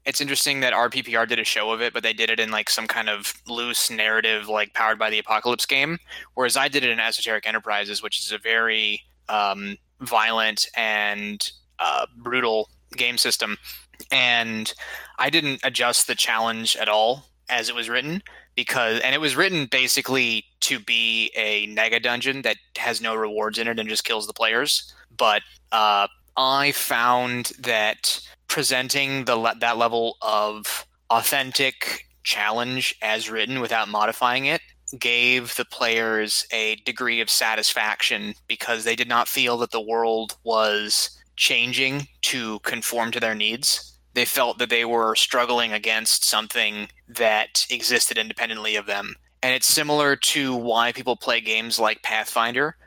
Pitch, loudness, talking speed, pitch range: 115 Hz, -21 LUFS, 160 wpm, 110-125 Hz